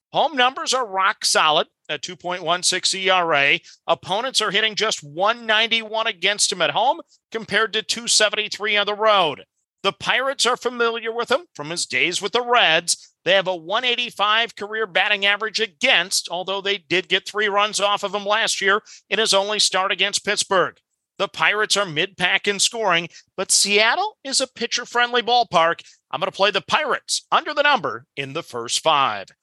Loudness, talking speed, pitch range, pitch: -19 LUFS, 175 wpm, 185-230 Hz, 205 Hz